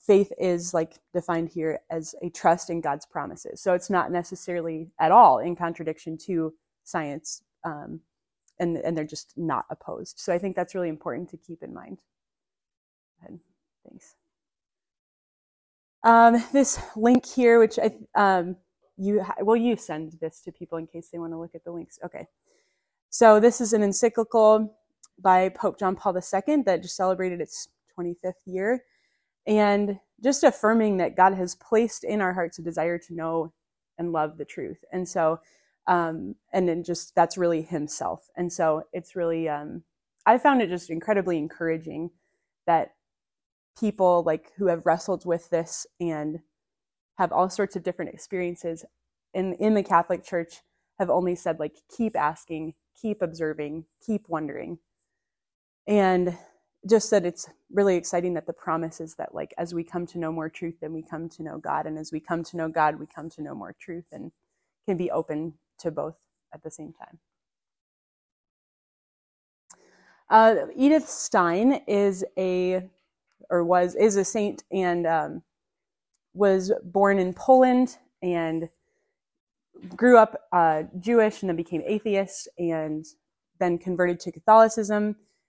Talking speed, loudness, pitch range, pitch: 160 wpm, -24 LUFS, 165-205 Hz, 175 Hz